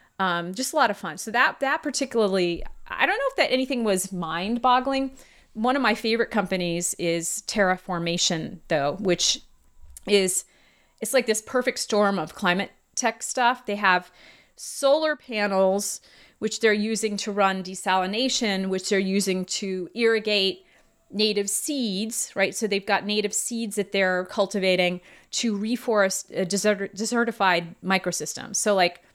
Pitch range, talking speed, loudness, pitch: 185-230 Hz, 145 wpm, -24 LUFS, 205 Hz